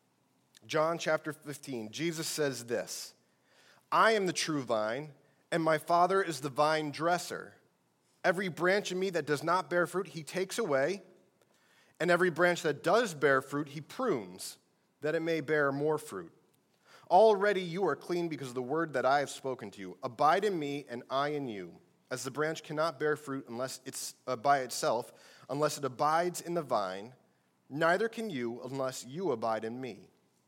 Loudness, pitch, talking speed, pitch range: -32 LUFS, 150 Hz, 180 wpm, 135-175 Hz